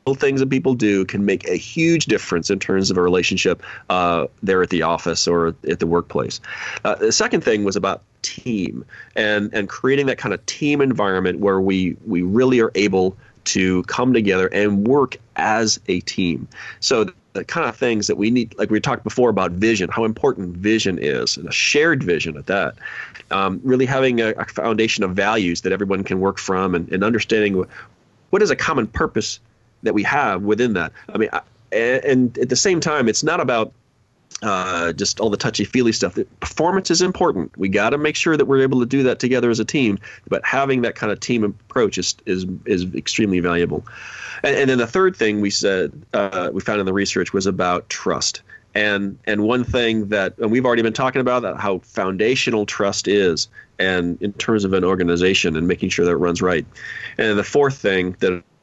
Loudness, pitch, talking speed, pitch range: -19 LUFS, 105 Hz, 210 wpm, 95-125 Hz